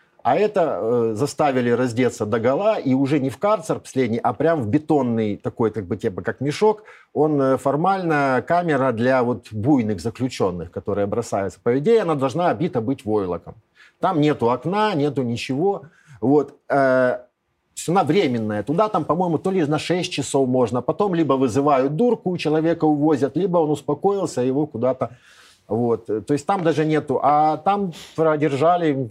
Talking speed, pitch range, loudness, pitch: 165 wpm, 125-160 Hz, -21 LUFS, 140 Hz